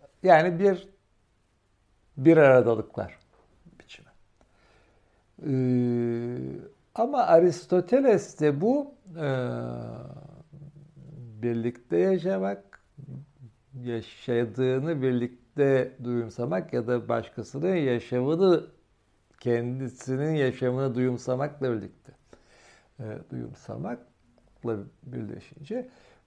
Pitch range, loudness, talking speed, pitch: 115-150 Hz, -26 LUFS, 60 wpm, 125 Hz